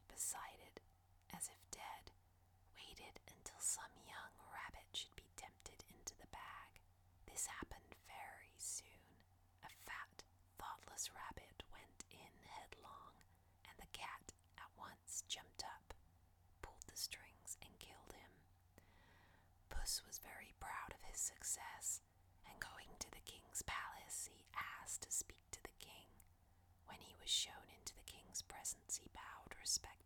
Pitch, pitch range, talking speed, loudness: 90 Hz, 85-90 Hz, 140 wpm, -50 LUFS